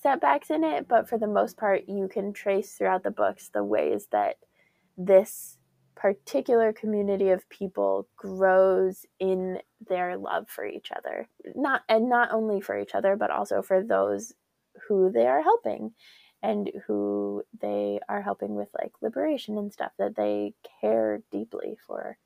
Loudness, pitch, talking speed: -27 LUFS, 190 Hz, 160 wpm